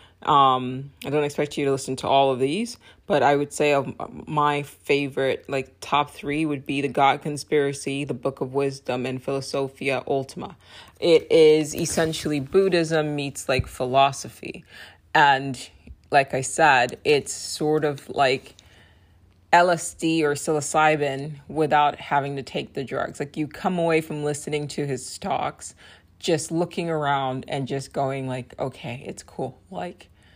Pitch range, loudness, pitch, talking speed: 135-150 Hz, -23 LUFS, 140 Hz, 150 wpm